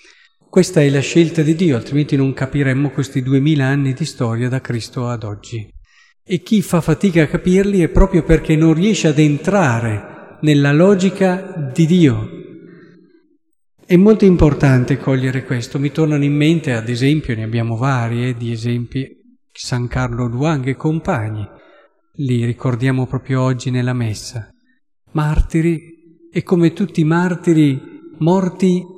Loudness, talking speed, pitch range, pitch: -16 LUFS, 145 wpm, 130-175 Hz, 150 Hz